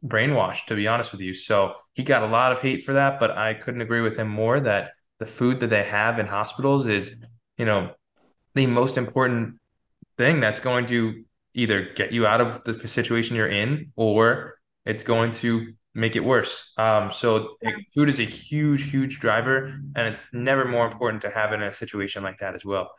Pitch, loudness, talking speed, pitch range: 115 Hz, -23 LUFS, 205 wpm, 110-125 Hz